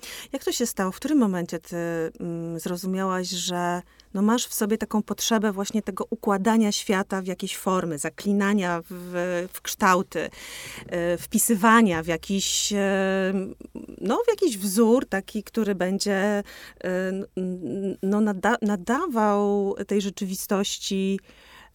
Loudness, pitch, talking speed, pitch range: -25 LUFS, 200 Hz, 115 wpm, 185-220 Hz